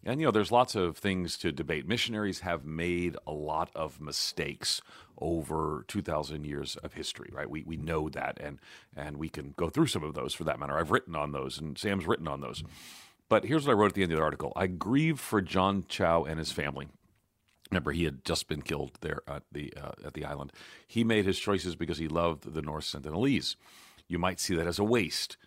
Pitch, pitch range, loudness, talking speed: 85 Hz, 75-100 Hz, -32 LUFS, 225 wpm